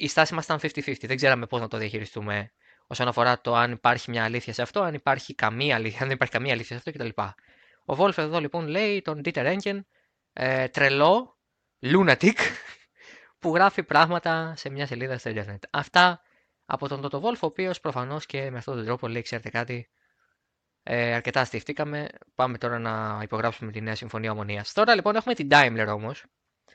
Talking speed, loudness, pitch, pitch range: 190 wpm, -25 LUFS, 130 Hz, 120-160 Hz